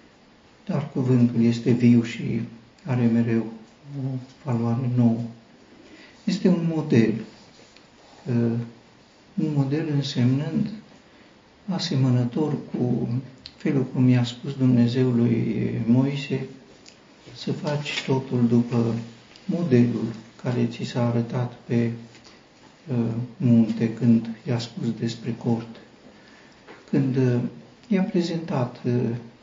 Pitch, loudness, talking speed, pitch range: 120 Hz, -24 LUFS, 90 wpm, 115-140 Hz